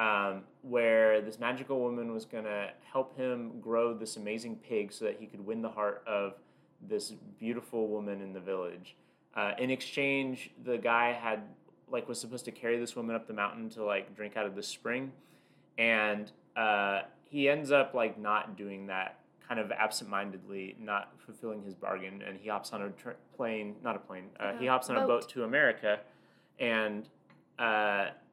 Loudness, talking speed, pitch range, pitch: -34 LUFS, 185 wpm, 100-120 Hz, 110 Hz